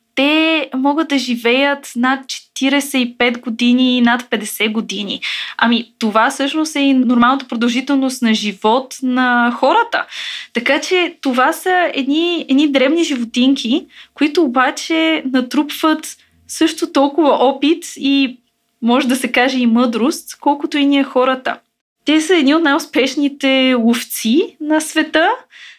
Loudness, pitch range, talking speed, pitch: -15 LUFS, 245-305 Hz, 130 wpm, 270 Hz